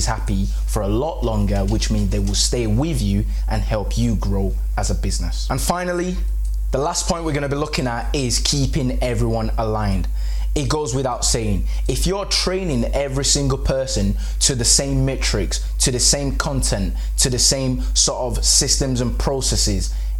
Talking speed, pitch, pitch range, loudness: 180 wpm, 120 Hz, 100-140 Hz, -20 LUFS